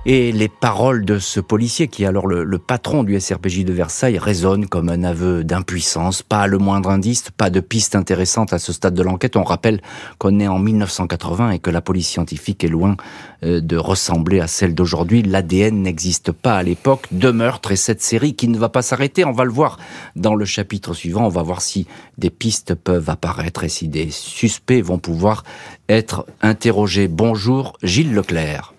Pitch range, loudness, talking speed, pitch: 90-110 Hz, -17 LUFS, 195 wpm, 95 Hz